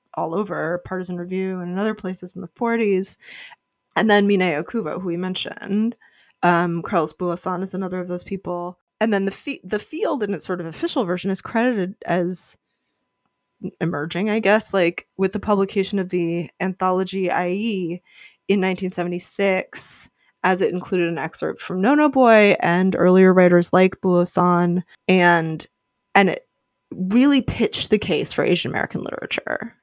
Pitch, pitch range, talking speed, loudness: 185 Hz, 175-205 Hz, 160 wpm, -20 LUFS